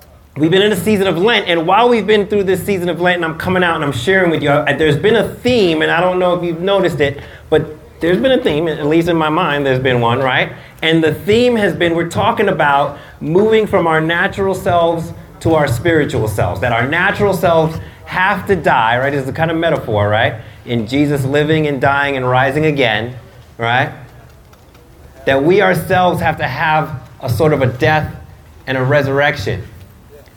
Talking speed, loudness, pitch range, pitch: 210 wpm, -14 LUFS, 135-180 Hz, 155 Hz